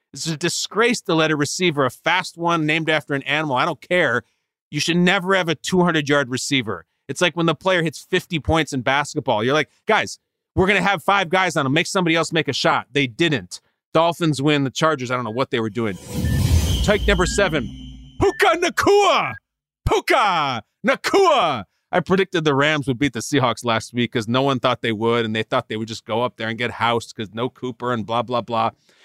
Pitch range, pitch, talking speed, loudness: 120-170 Hz, 145 Hz, 220 wpm, -20 LUFS